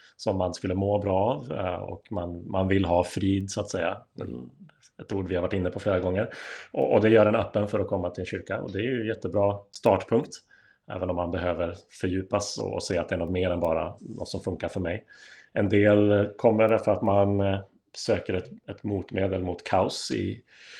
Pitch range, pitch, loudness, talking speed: 90-105 Hz, 95 Hz, -27 LUFS, 220 wpm